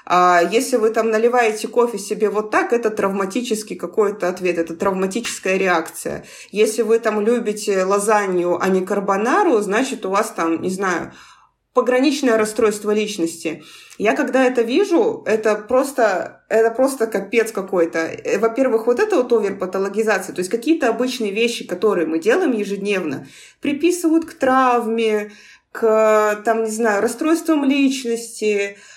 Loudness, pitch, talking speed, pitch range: -18 LUFS, 220 Hz, 135 wpm, 200-240 Hz